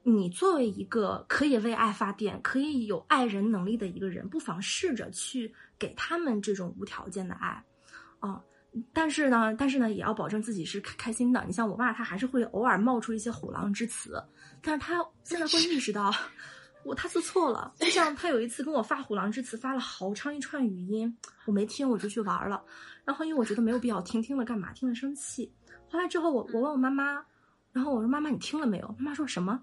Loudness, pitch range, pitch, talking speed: -30 LUFS, 215-280 Hz, 240 Hz, 330 characters per minute